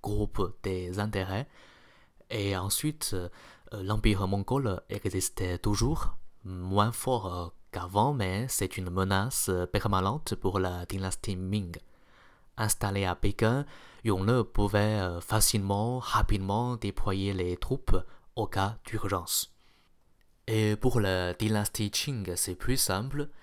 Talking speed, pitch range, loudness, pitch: 105 wpm, 95-110 Hz, -30 LUFS, 100 Hz